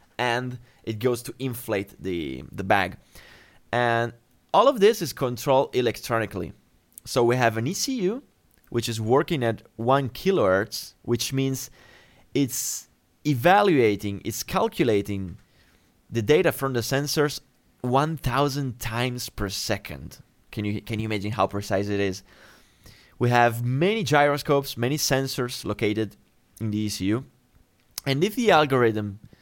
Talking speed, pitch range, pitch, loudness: 140 wpm, 110-135 Hz, 120 Hz, -24 LUFS